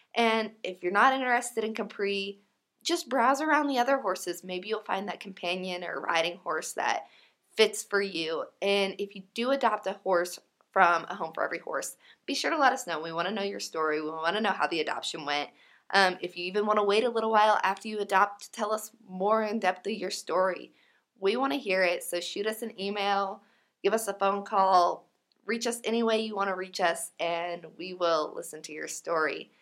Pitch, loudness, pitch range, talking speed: 200 Hz, -29 LUFS, 180-220 Hz, 225 wpm